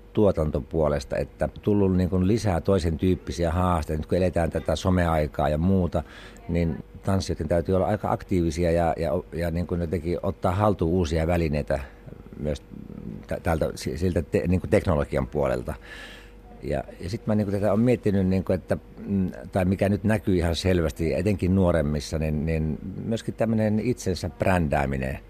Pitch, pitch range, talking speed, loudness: 90 Hz, 80-95 Hz, 150 wpm, -25 LUFS